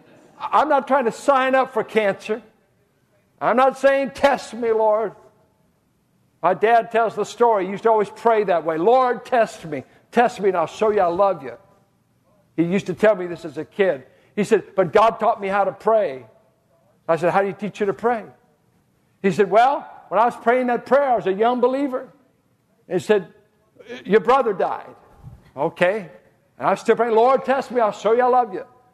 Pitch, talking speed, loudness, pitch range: 215 Hz, 205 wpm, -20 LUFS, 195-240 Hz